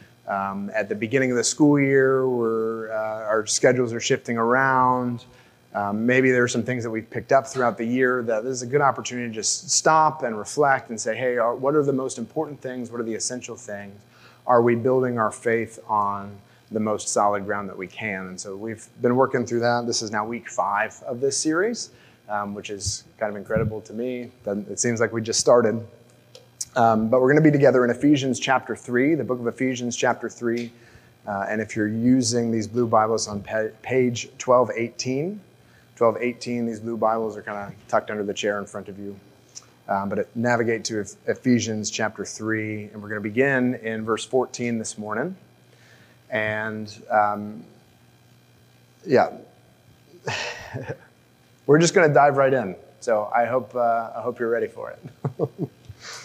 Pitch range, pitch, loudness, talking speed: 105-125 Hz, 115 Hz, -23 LUFS, 190 wpm